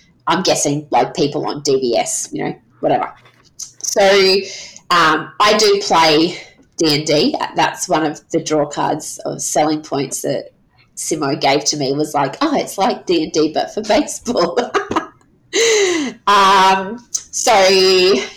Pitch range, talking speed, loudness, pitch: 155-210 Hz, 150 wpm, -15 LUFS, 190 Hz